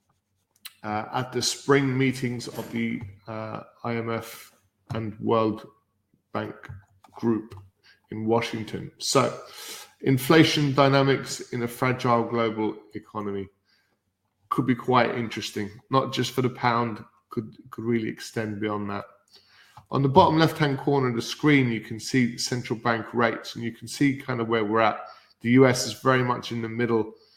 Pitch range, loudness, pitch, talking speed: 110-130 Hz, -25 LUFS, 115 Hz, 155 wpm